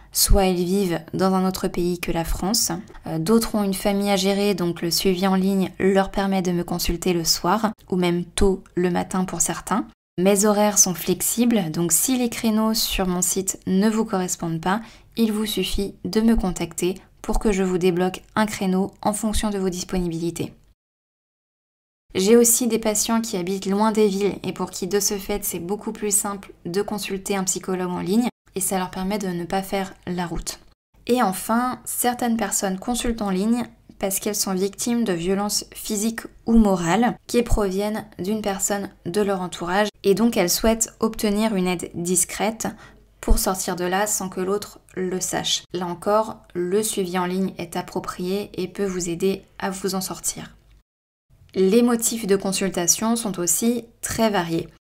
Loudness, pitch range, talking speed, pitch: -22 LUFS, 180-210 Hz, 185 wpm, 195 Hz